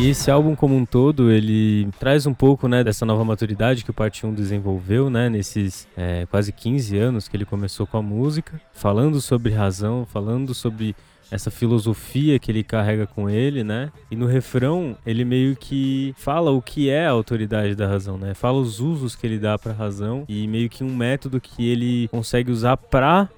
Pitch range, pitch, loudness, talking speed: 105-130 Hz, 120 Hz, -21 LUFS, 195 wpm